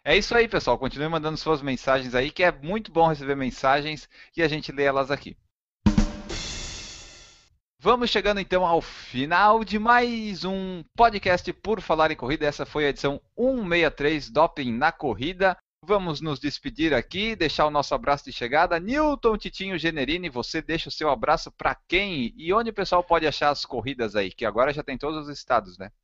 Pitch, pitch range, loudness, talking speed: 160 Hz, 140-195 Hz, -24 LUFS, 180 wpm